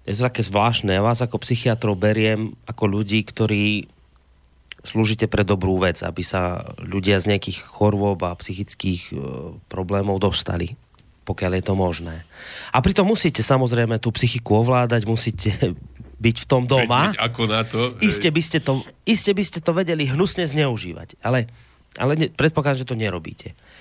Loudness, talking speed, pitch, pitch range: -21 LUFS, 150 wpm, 110 Hz, 100-125 Hz